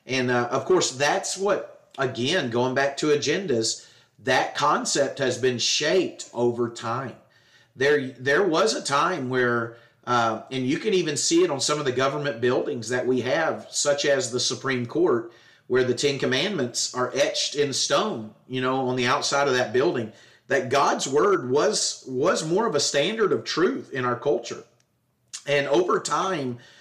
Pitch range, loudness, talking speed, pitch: 120-140 Hz, -24 LUFS, 175 wpm, 130 Hz